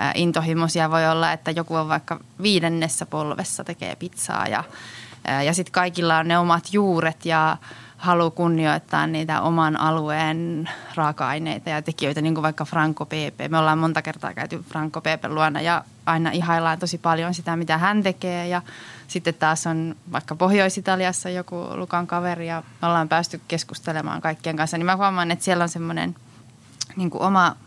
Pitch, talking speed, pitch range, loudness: 165 Hz, 165 wpm, 155-175 Hz, -23 LUFS